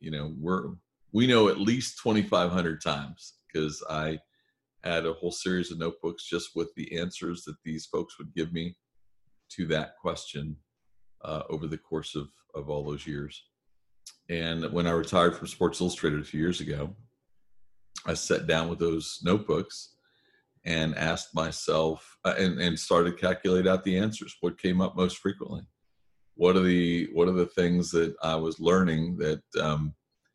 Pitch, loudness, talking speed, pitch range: 85 Hz, -29 LUFS, 170 wpm, 80-90 Hz